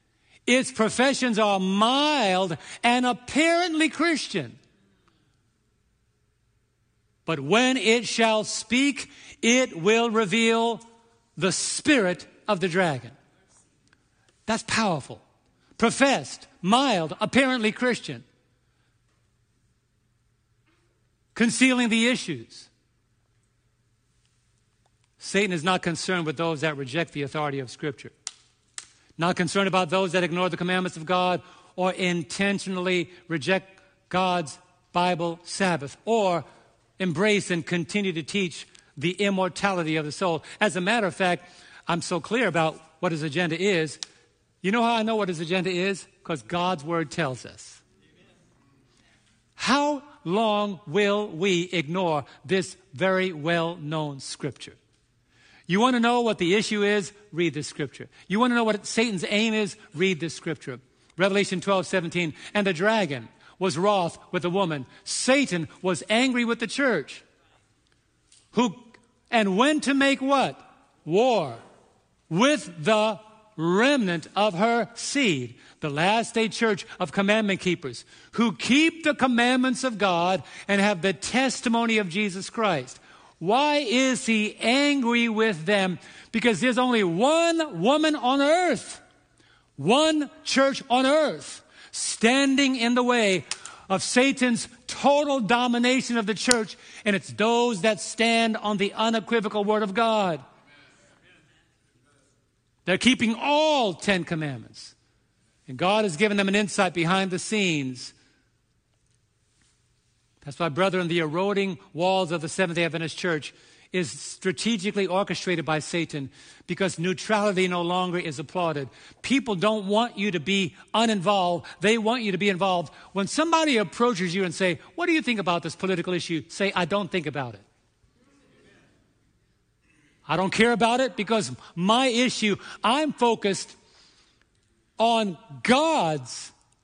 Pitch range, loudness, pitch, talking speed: 165-225 Hz, -24 LUFS, 190 Hz, 130 wpm